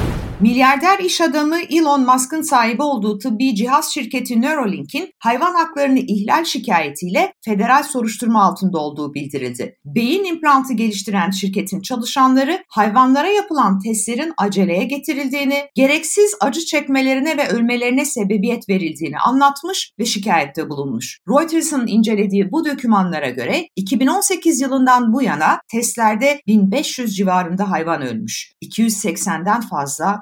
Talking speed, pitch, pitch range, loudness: 115 wpm, 245 Hz, 200-285 Hz, -17 LUFS